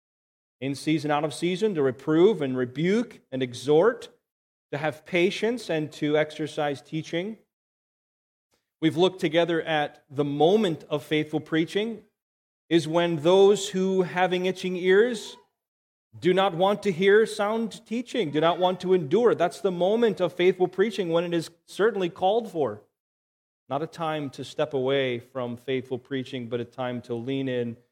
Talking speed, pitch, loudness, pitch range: 155 wpm, 165 Hz, -25 LUFS, 140-190 Hz